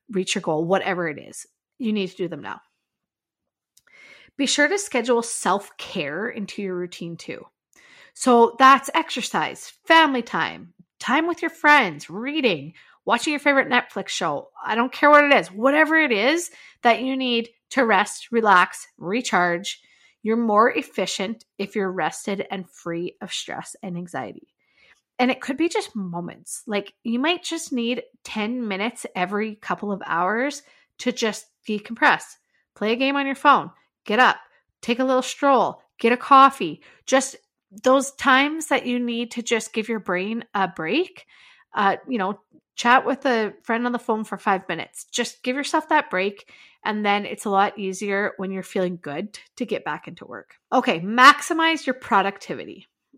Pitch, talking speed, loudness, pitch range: 235 Hz, 170 wpm, -21 LUFS, 195-270 Hz